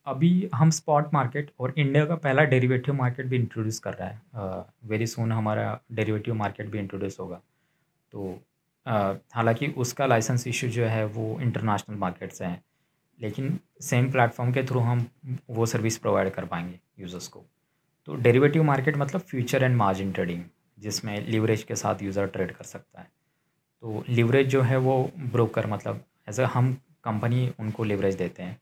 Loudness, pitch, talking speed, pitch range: -26 LUFS, 115 Hz, 170 wpm, 105-130 Hz